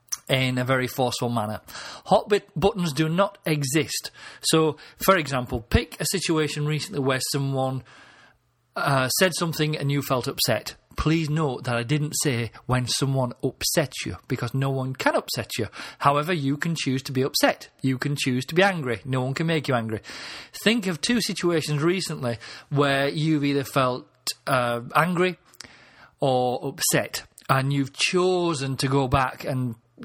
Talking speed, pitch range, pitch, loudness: 165 wpm, 130-160 Hz, 140 Hz, -24 LUFS